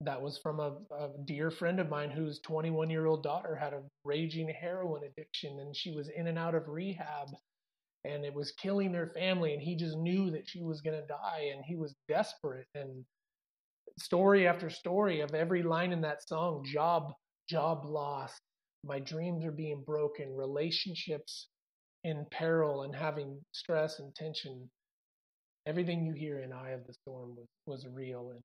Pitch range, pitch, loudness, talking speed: 145-165 Hz, 155 Hz, -36 LUFS, 180 wpm